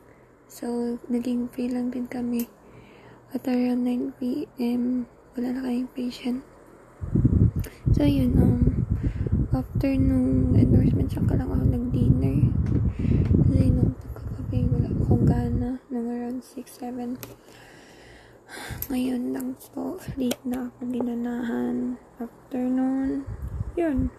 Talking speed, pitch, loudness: 115 wpm, 245 Hz, -25 LUFS